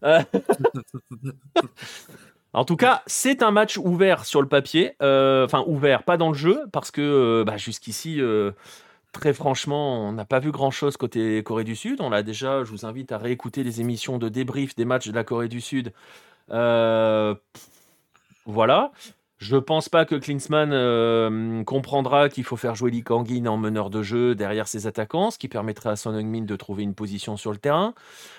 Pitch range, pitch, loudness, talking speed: 110-145 Hz, 125 Hz, -23 LUFS, 190 wpm